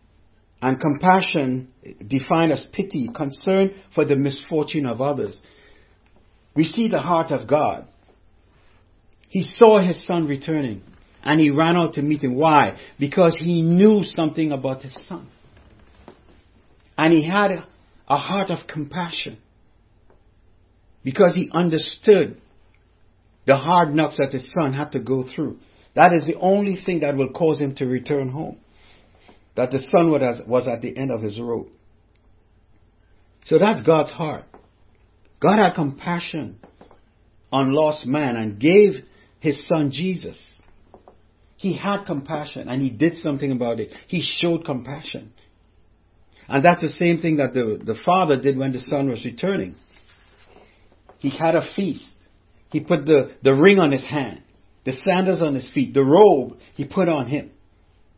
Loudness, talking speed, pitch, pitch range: -20 LUFS, 150 wpm, 140 Hz, 105-165 Hz